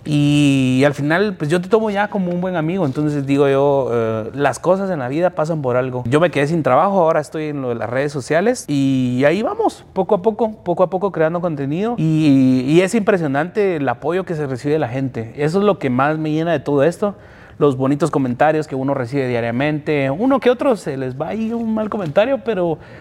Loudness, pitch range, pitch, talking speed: -17 LUFS, 140-185 Hz, 155 Hz, 230 wpm